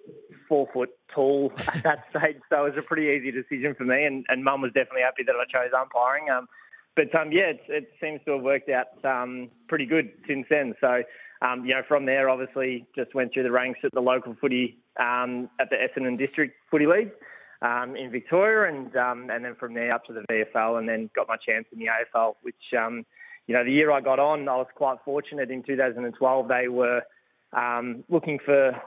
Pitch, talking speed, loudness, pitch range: 130 Hz, 220 wpm, -25 LUFS, 125-145 Hz